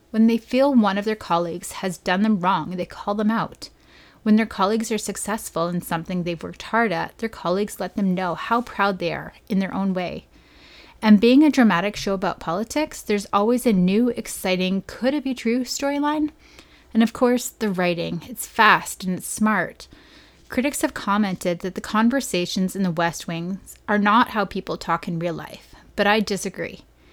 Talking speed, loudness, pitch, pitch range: 190 wpm, -22 LUFS, 205 Hz, 185-230 Hz